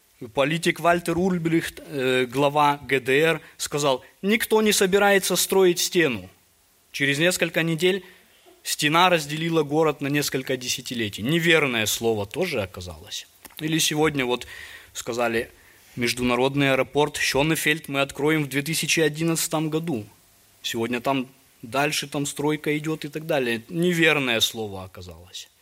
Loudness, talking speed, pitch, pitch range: -22 LUFS, 110 wpm, 150 Hz, 125-165 Hz